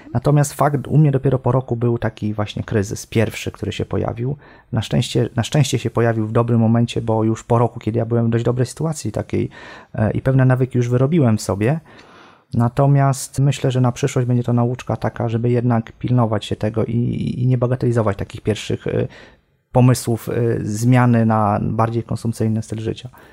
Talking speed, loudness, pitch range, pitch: 180 wpm, -19 LUFS, 110-125 Hz, 120 Hz